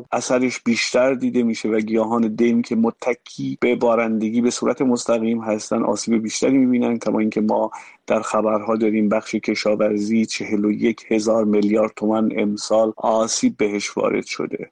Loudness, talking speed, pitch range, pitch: -20 LUFS, 150 wpm, 110-115 Hz, 110 Hz